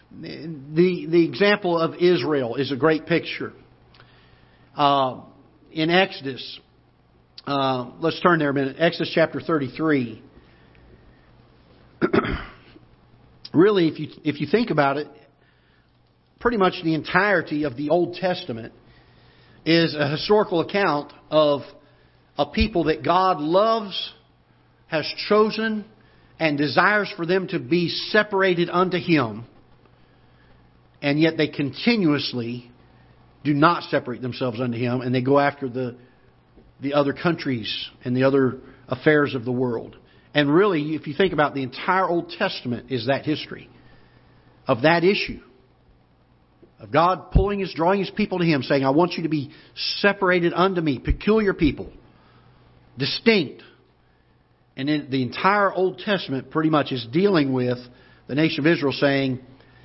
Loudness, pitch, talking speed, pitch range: -22 LUFS, 150 Hz, 135 wpm, 130-175 Hz